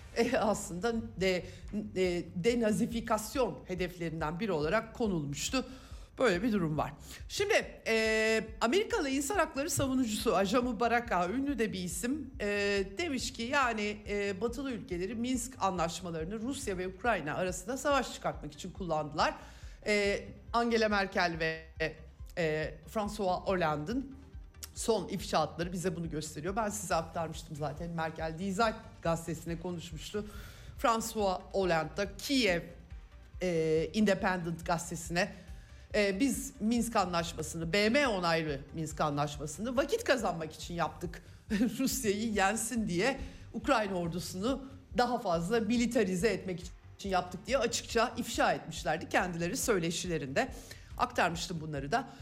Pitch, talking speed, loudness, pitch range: 200 Hz, 115 wpm, -33 LUFS, 170-235 Hz